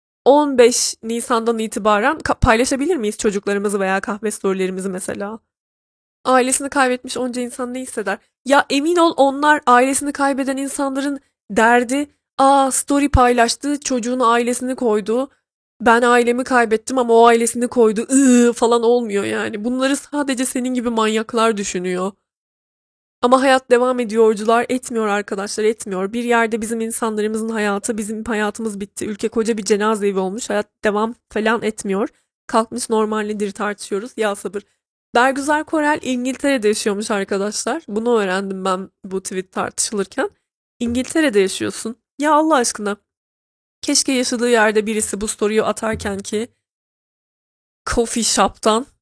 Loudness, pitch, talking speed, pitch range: -18 LUFS, 230 Hz, 125 wpm, 210-255 Hz